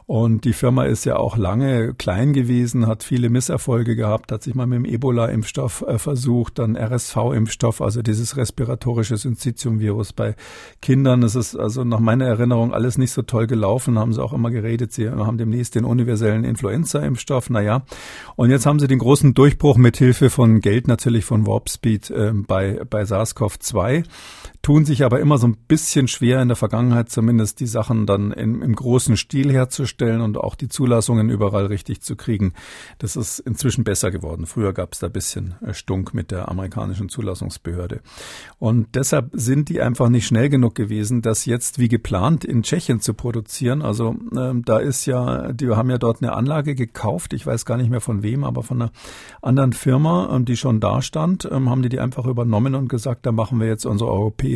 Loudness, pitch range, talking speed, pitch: -19 LUFS, 110-130 Hz, 190 wpm, 120 Hz